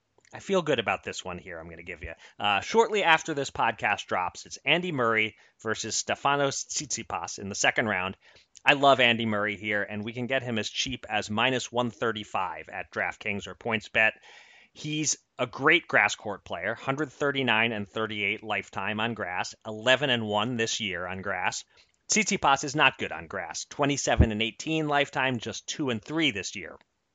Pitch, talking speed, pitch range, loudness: 120 Hz, 180 wpm, 105-140 Hz, -27 LUFS